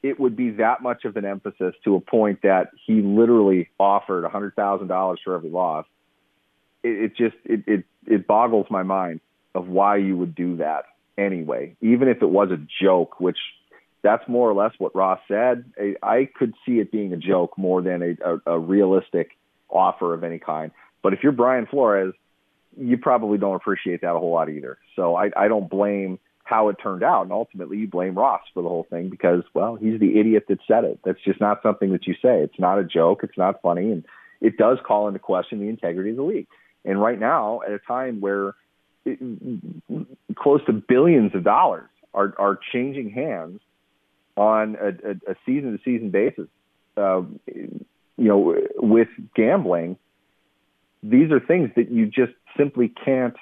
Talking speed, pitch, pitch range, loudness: 190 wpm, 100 Hz, 95-120 Hz, -21 LUFS